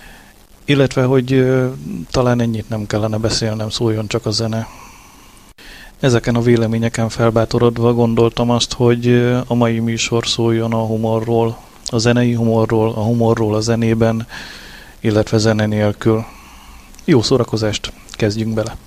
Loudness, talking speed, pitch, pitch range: -16 LUFS, 125 wpm, 115 Hz, 110-120 Hz